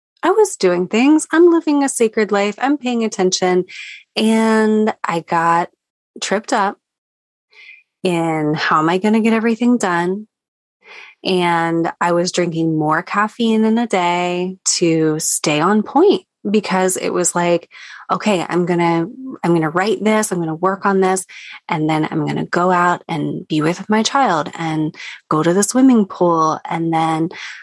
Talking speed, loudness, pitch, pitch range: 160 wpm, -16 LUFS, 185 Hz, 170-225 Hz